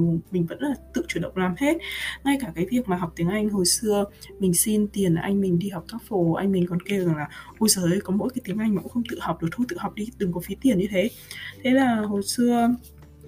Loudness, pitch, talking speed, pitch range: -24 LUFS, 195 Hz, 275 wpm, 175-230 Hz